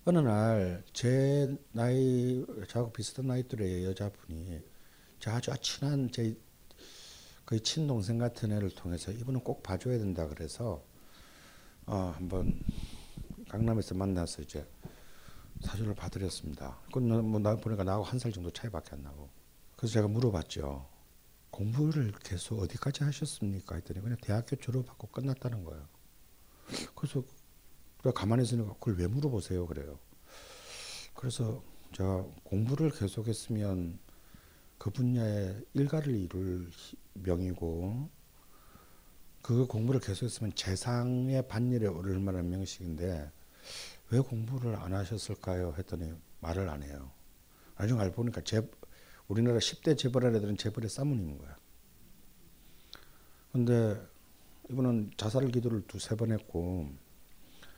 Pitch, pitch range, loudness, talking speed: 105 Hz, 90-120 Hz, -34 LUFS, 275 characters per minute